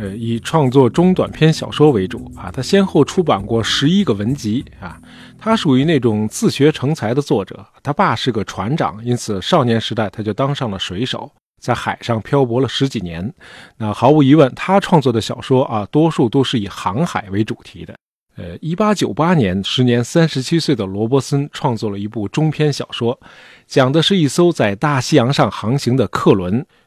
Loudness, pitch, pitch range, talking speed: -16 LUFS, 130 Hz, 110-150 Hz, 285 characters per minute